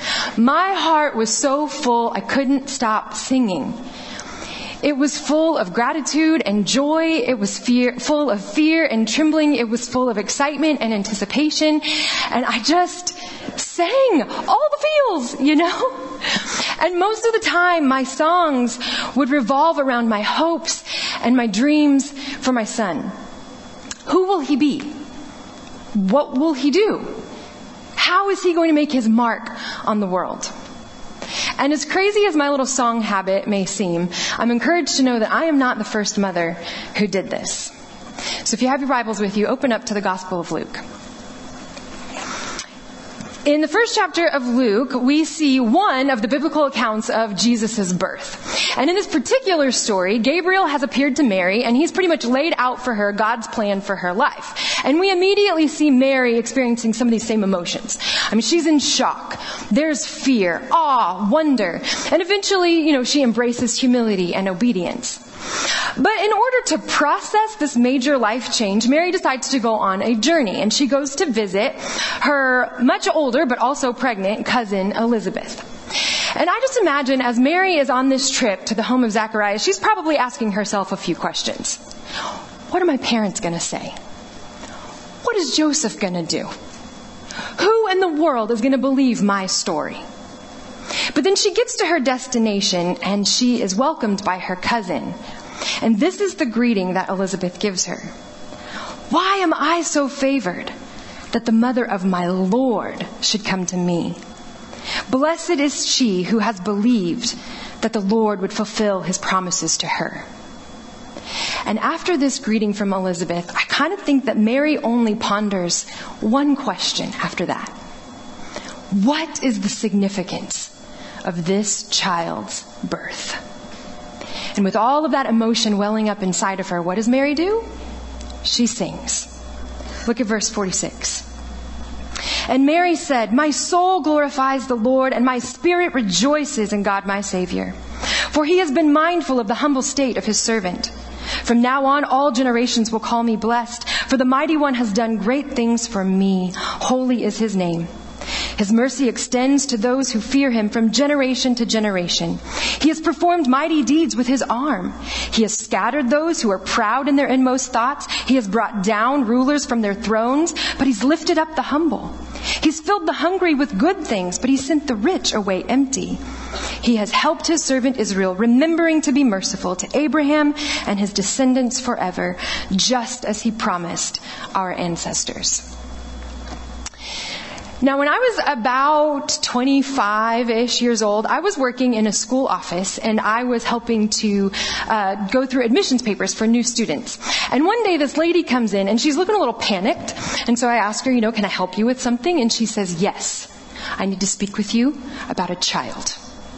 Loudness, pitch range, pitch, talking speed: -19 LUFS, 215-295 Hz, 250 Hz, 170 wpm